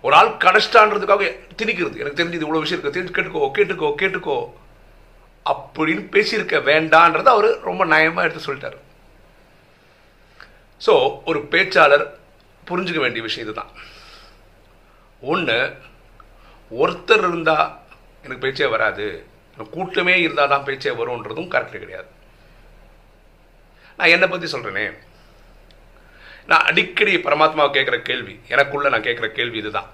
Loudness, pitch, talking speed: -18 LUFS, 200 Hz, 110 wpm